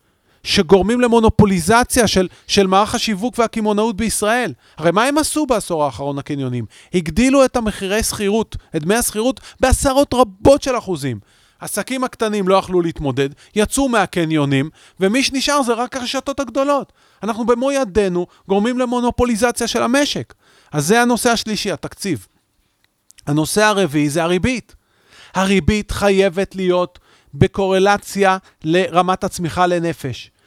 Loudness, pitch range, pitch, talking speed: -17 LUFS, 170-240 Hz, 200 Hz, 120 wpm